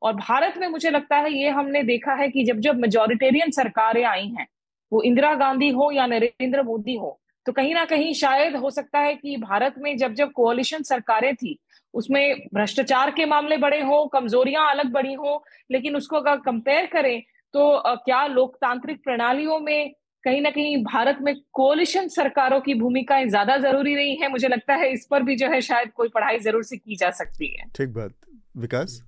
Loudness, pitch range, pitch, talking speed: -22 LUFS, 240-290 Hz, 270 Hz, 195 wpm